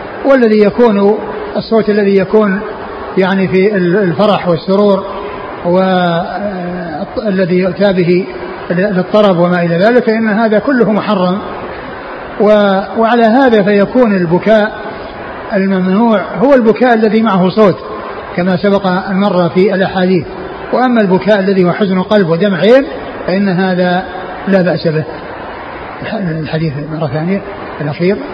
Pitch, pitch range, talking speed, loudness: 195 Hz, 185-215 Hz, 110 wpm, -11 LUFS